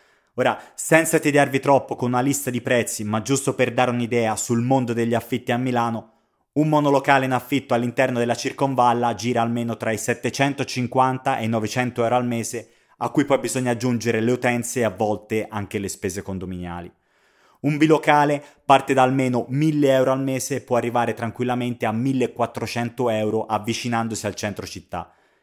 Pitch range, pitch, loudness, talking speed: 115-135 Hz, 120 Hz, -21 LUFS, 170 wpm